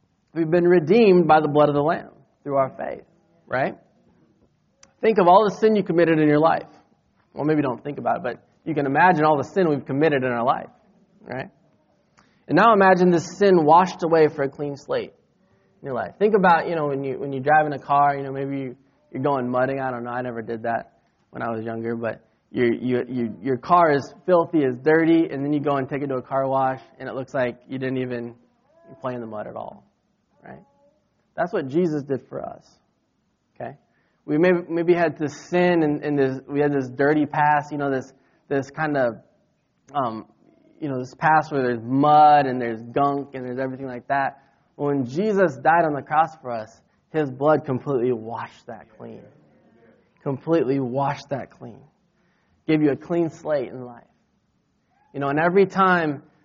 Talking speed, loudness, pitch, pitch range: 205 wpm, -21 LUFS, 140 Hz, 130-160 Hz